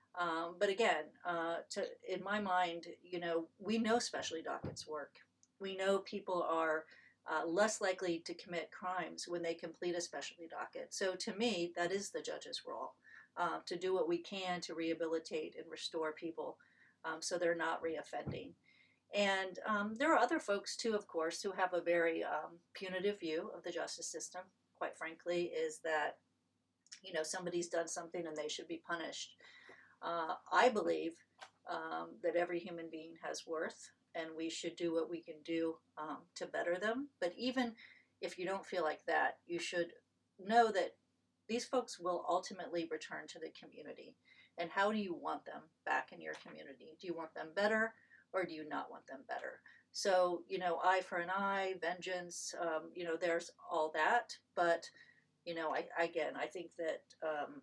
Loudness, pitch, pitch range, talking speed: -40 LUFS, 175 Hz, 165-195 Hz, 185 wpm